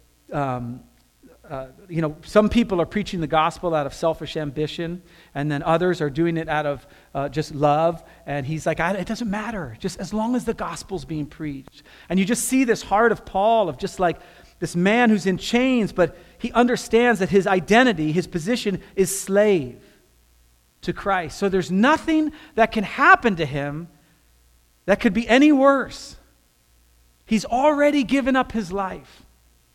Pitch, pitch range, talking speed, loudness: 175 Hz, 150-220 Hz, 175 wpm, -21 LUFS